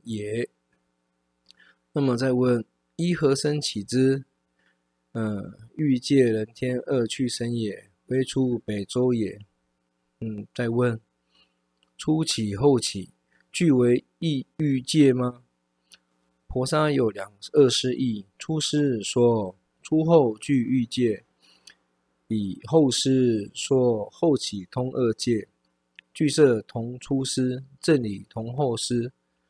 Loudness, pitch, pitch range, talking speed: -24 LUFS, 115 Hz, 90-130 Hz, 145 characters per minute